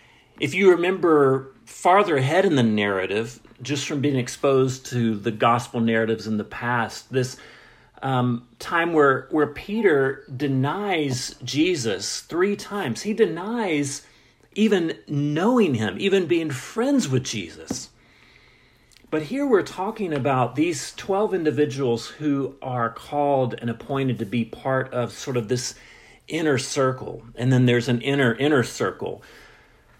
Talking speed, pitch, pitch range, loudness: 135 wpm, 135 Hz, 120-155 Hz, -23 LUFS